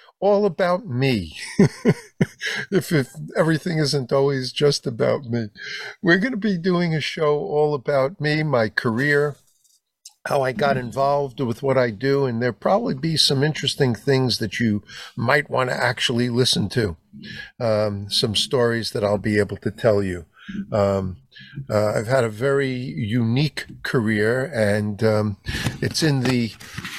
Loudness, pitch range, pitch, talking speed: -21 LUFS, 110-150 Hz, 130 Hz, 155 wpm